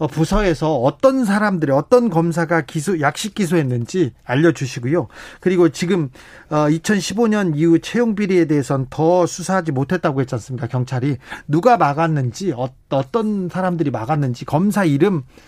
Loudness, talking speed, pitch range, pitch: -18 LUFS, 335 characters per minute, 140-185 Hz, 165 Hz